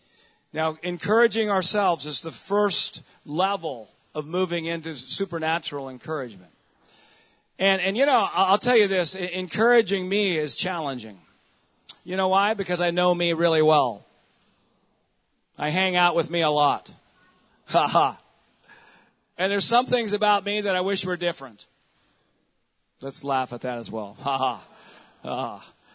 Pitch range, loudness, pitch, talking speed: 155-195 Hz, -23 LUFS, 180 Hz, 140 wpm